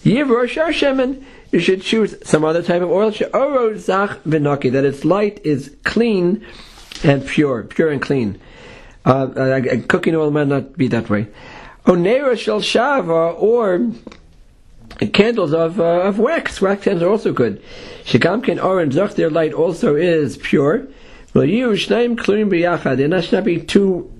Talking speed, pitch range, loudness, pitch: 120 wpm, 150-220 Hz, -17 LUFS, 185 Hz